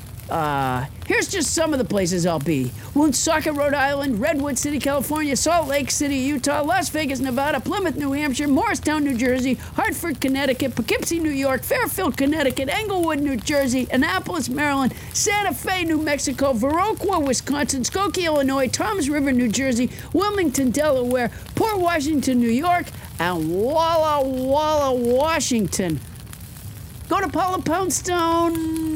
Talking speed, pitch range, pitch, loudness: 135 wpm, 265-330 Hz, 290 Hz, -21 LUFS